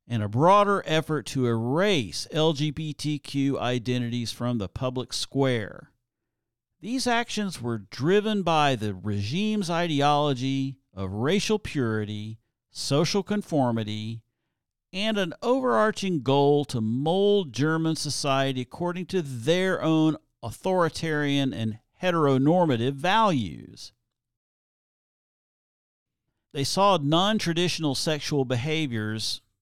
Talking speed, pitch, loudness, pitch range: 95 wpm, 145 Hz, -25 LUFS, 120-170 Hz